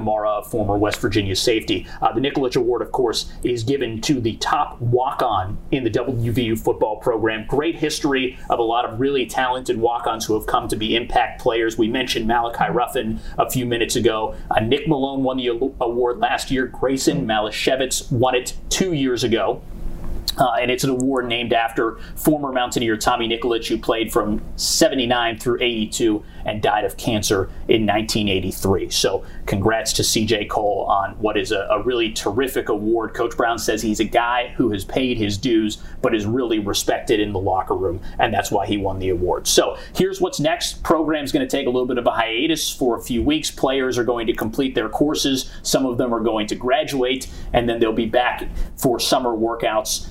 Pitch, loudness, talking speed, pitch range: 120 Hz, -20 LUFS, 200 wpm, 110-130 Hz